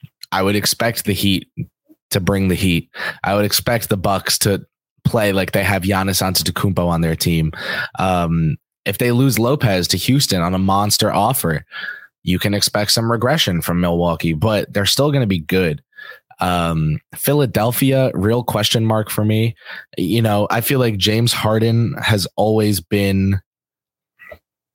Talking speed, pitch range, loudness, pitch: 160 wpm, 90-115 Hz, -17 LUFS, 100 Hz